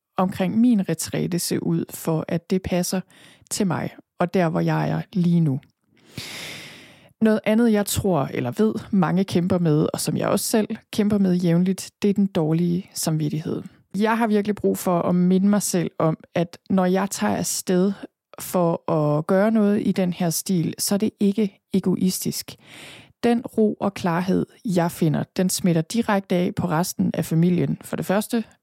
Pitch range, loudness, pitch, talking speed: 170-205 Hz, -22 LUFS, 185 Hz, 180 wpm